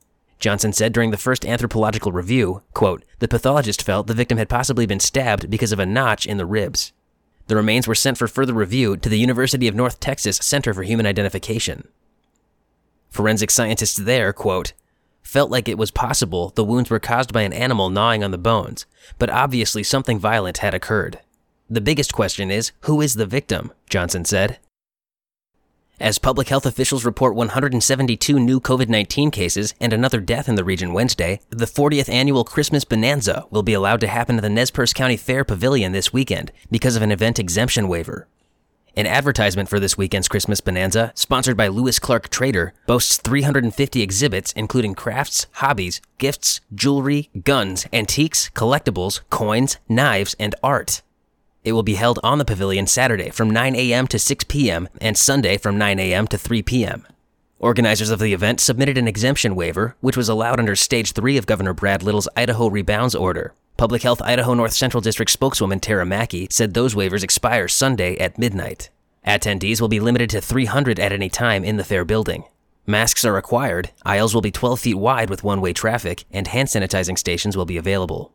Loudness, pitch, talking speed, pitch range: -19 LUFS, 115 Hz, 180 wpm, 100-125 Hz